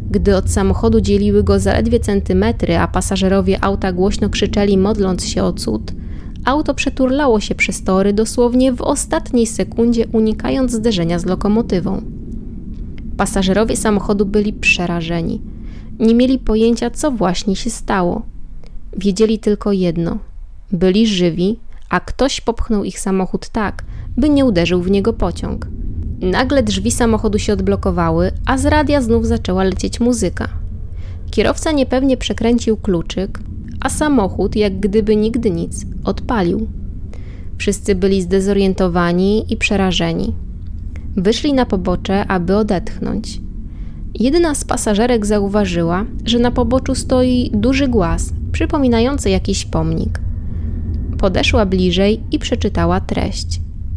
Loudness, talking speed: -16 LUFS, 120 wpm